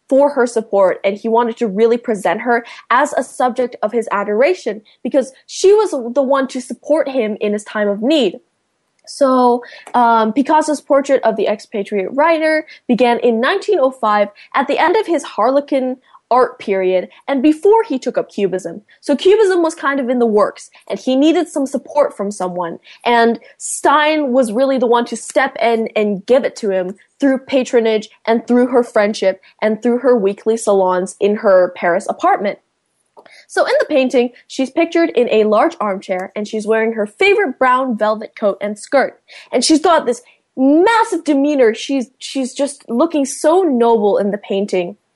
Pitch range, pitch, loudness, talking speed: 215-280 Hz, 245 Hz, -15 LUFS, 175 wpm